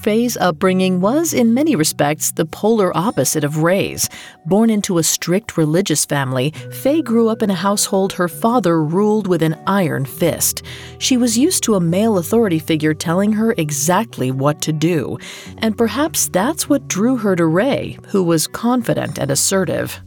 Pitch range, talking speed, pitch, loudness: 160-225 Hz, 170 wpm, 185 Hz, -16 LUFS